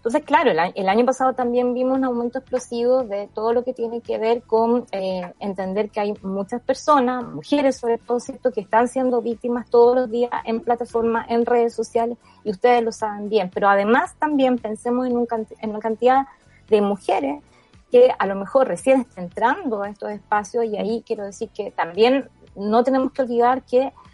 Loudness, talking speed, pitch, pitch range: -21 LUFS, 190 wpm, 235 Hz, 215-255 Hz